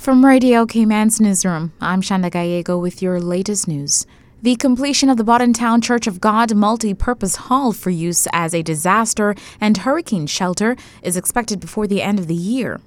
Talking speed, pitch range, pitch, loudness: 180 wpm, 180-235 Hz, 210 Hz, -17 LUFS